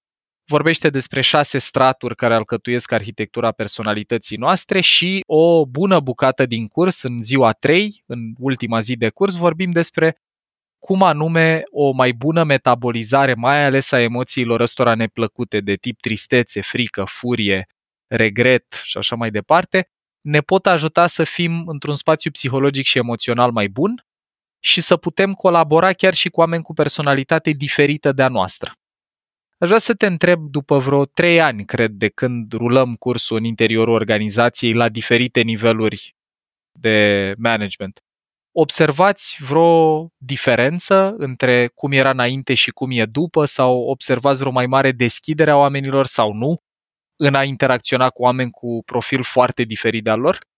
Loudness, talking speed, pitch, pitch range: -16 LUFS, 150 wpm, 130 Hz, 115-160 Hz